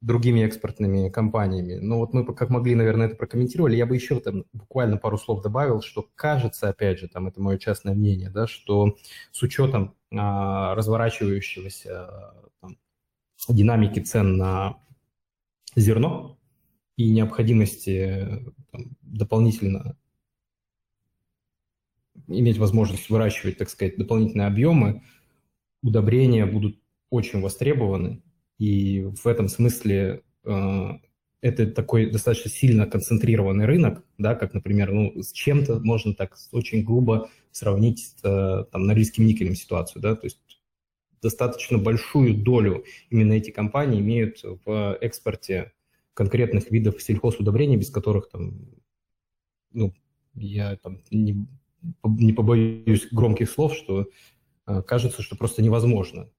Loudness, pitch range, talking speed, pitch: -23 LUFS, 100-120 Hz, 120 wpm, 110 Hz